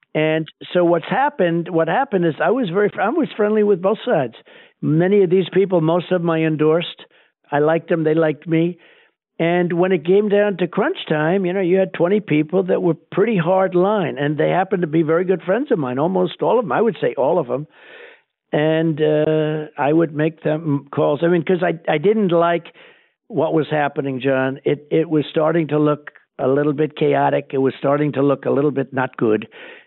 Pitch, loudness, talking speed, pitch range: 170 Hz, -18 LUFS, 215 wpm, 155-190 Hz